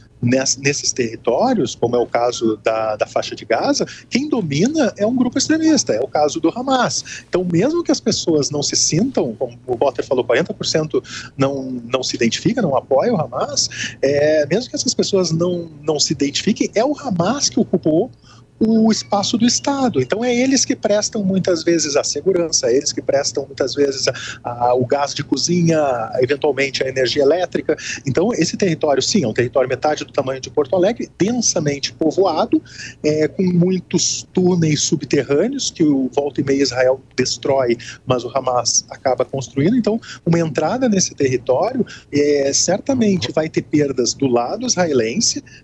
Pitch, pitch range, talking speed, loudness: 155 Hz, 135-200 Hz, 170 wpm, -18 LUFS